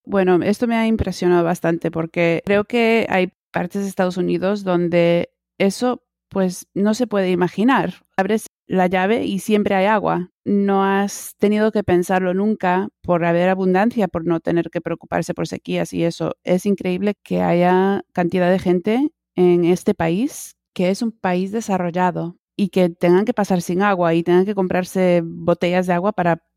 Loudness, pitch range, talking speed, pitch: -19 LUFS, 175-205 Hz, 170 wpm, 185 Hz